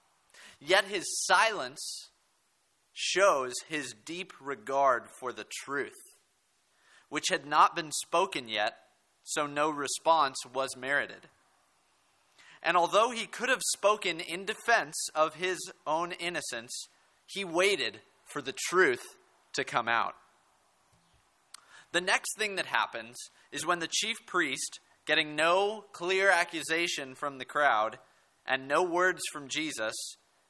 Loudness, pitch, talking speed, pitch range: -30 LUFS, 160 Hz, 125 wpm, 140-185 Hz